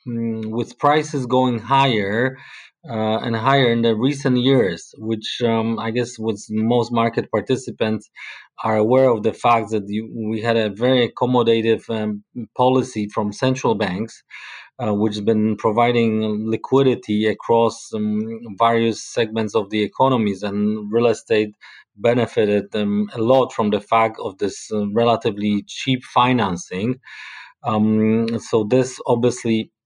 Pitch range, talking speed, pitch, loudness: 110-120 Hz, 140 wpm, 115 Hz, -19 LUFS